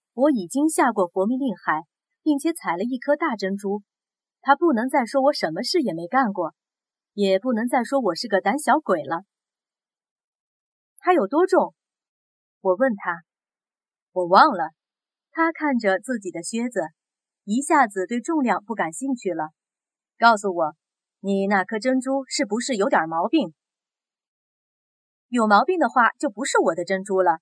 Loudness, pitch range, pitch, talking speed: -22 LUFS, 190-275 Hz, 235 Hz, 220 characters per minute